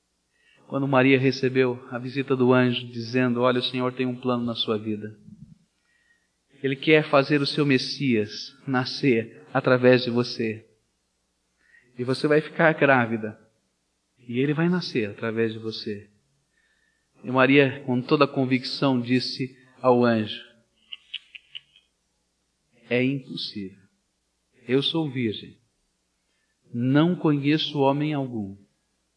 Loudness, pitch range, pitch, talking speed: -23 LUFS, 110-135 Hz, 125 Hz, 115 wpm